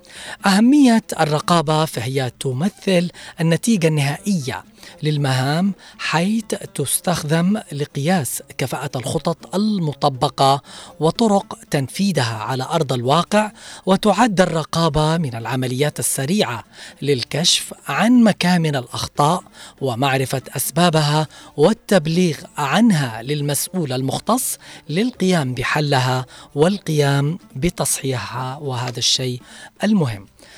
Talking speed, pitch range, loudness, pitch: 80 wpm, 135-190 Hz, -19 LUFS, 155 Hz